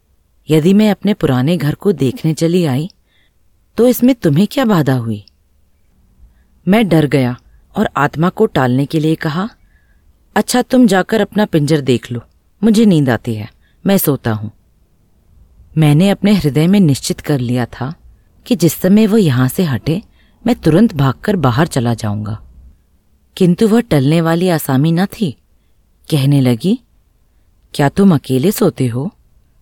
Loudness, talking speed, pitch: -14 LUFS, 150 wpm, 150 Hz